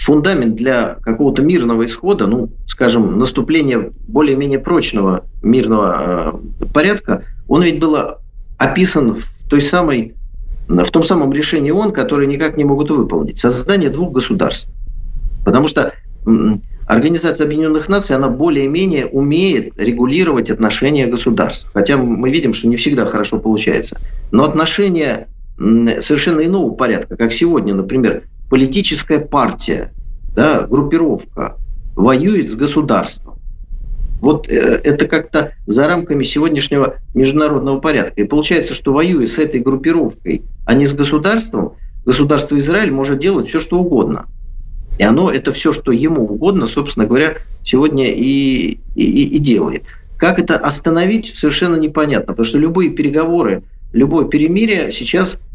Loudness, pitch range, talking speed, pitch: -14 LUFS, 125-165 Hz, 125 wpm, 145 Hz